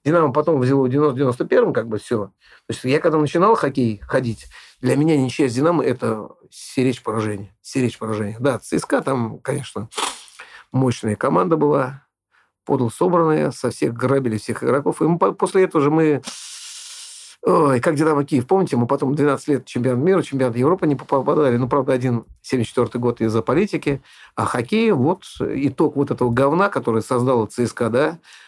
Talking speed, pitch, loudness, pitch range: 165 wpm, 135 Hz, -19 LUFS, 125-155 Hz